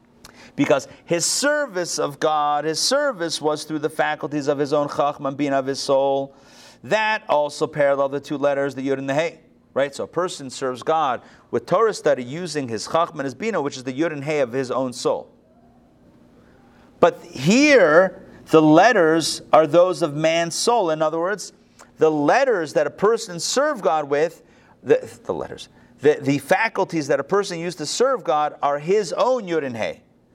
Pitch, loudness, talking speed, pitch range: 155 Hz, -20 LUFS, 185 wpm, 140-180 Hz